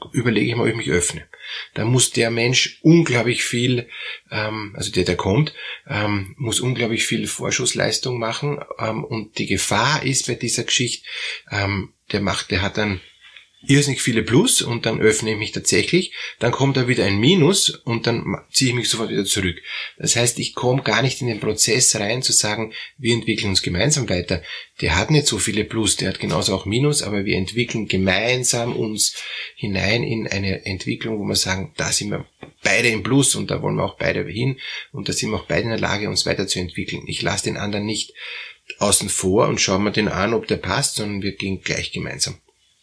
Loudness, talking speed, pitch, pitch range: -20 LUFS, 200 wpm, 110 Hz, 100-125 Hz